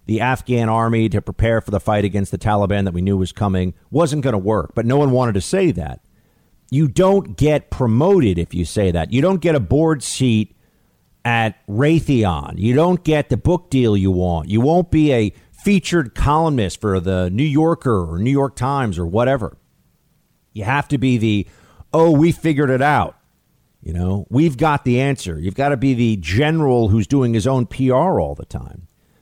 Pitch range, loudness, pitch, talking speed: 100-145 Hz, -17 LUFS, 120 Hz, 200 wpm